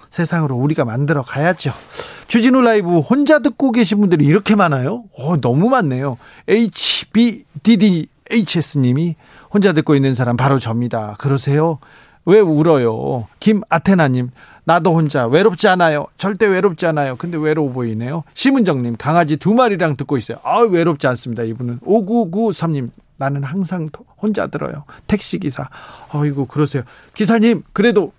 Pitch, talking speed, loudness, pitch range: 165 Hz, 330 characters per minute, -16 LUFS, 140-205 Hz